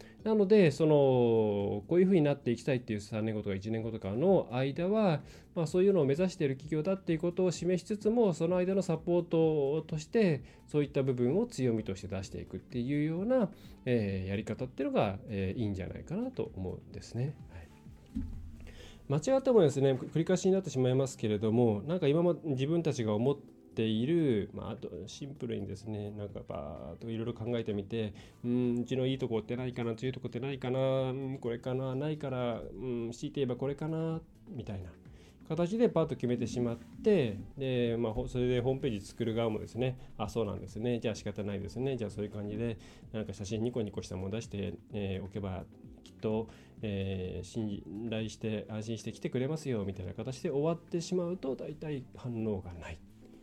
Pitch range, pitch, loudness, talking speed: 105-150 Hz, 120 Hz, -33 LUFS, 410 characters per minute